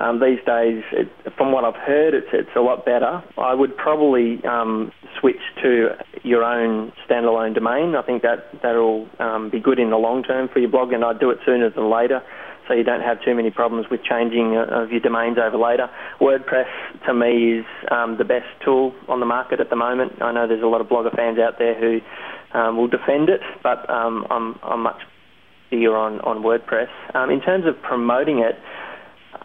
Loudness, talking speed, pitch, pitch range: -20 LUFS, 210 wpm, 115 Hz, 115-125 Hz